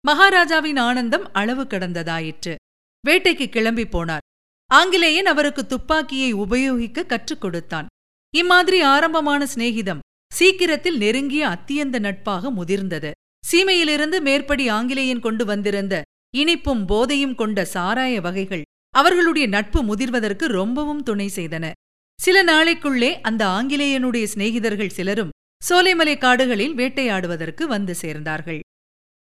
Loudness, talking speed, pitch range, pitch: -19 LUFS, 100 wpm, 200-295 Hz, 250 Hz